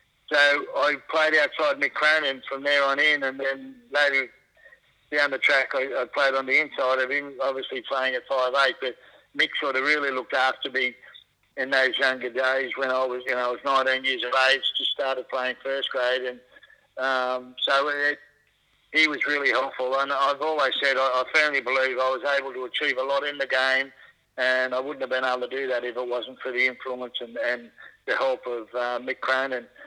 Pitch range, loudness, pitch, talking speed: 125-135 Hz, -24 LUFS, 130 Hz, 215 wpm